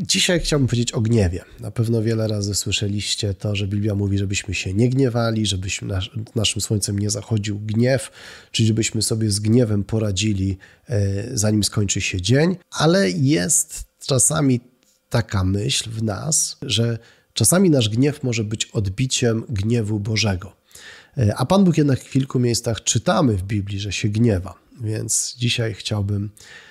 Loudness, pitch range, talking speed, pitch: -20 LUFS, 100-125 Hz, 150 wpm, 110 Hz